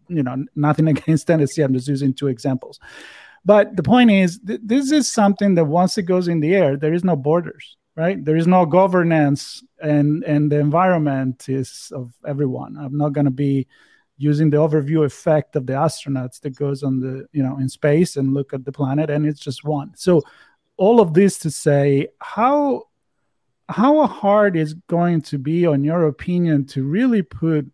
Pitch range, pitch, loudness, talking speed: 140-180 Hz, 150 Hz, -18 LUFS, 195 wpm